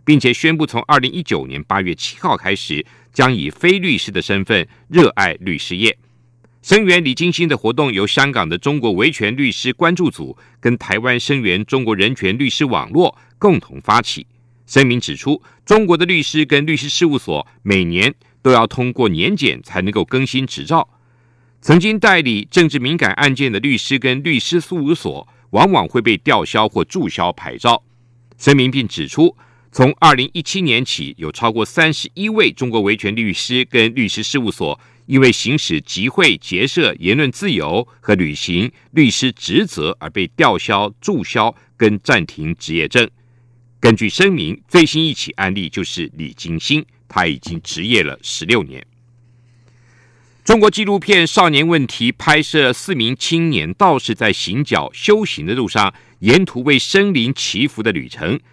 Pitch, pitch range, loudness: 130 Hz, 115-155 Hz, -15 LUFS